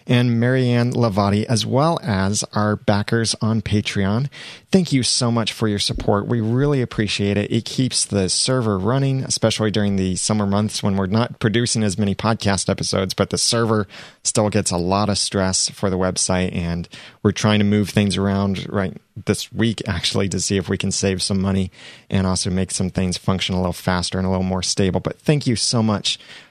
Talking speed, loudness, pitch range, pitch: 200 wpm, -20 LUFS, 95-115 Hz, 105 Hz